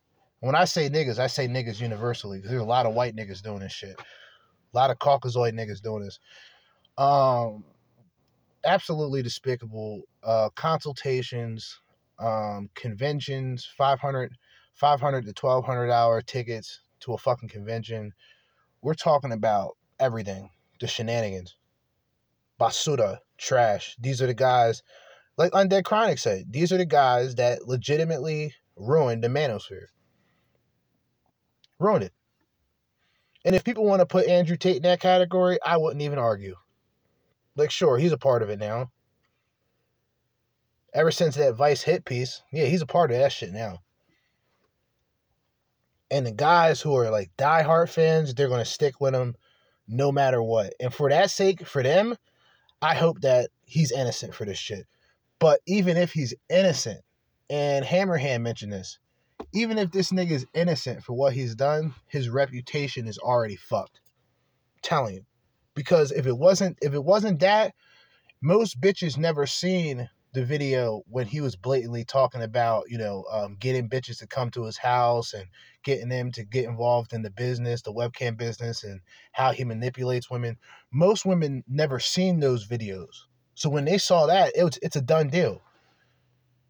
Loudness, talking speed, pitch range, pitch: -25 LUFS, 160 wpm, 120-155 Hz, 130 Hz